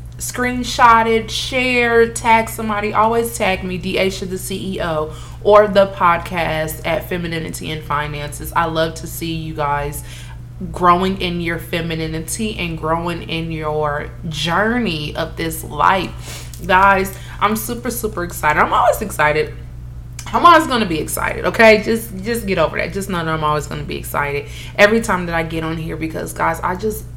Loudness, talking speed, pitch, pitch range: -17 LUFS, 165 wpm, 165 Hz, 150-195 Hz